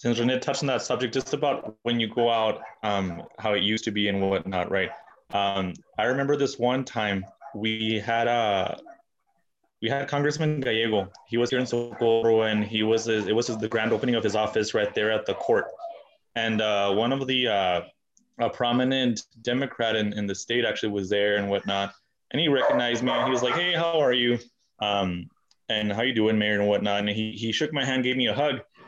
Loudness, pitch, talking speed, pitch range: -25 LUFS, 115 Hz, 215 wpm, 105-130 Hz